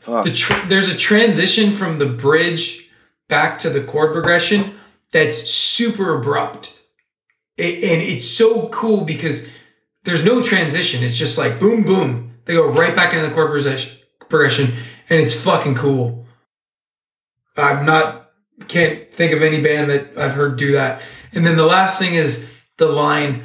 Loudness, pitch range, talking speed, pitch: -15 LUFS, 140-190 Hz, 160 wpm, 160 Hz